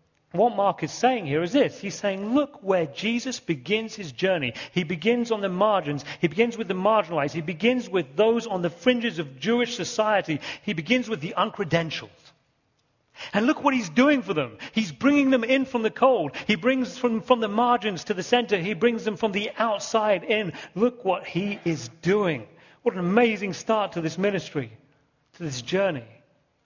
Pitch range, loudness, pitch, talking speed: 175-235 Hz, -24 LUFS, 205 Hz, 195 wpm